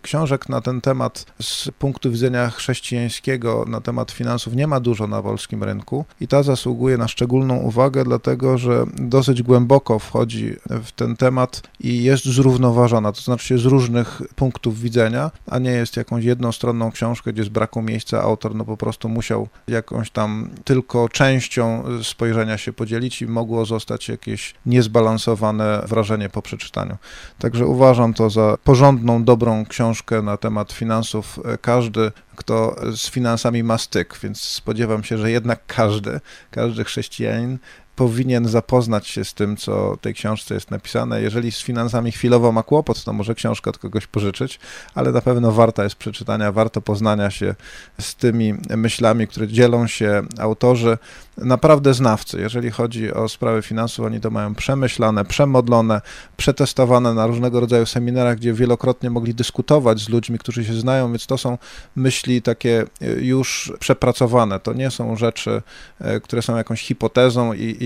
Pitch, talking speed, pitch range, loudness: 115 Hz, 155 wpm, 110-125 Hz, -19 LUFS